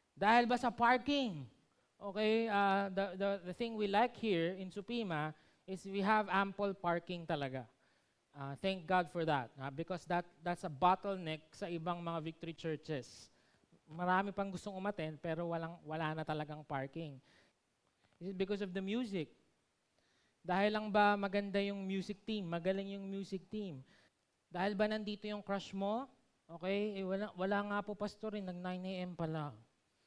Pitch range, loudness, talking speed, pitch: 165-205 Hz, -38 LUFS, 165 wpm, 190 Hz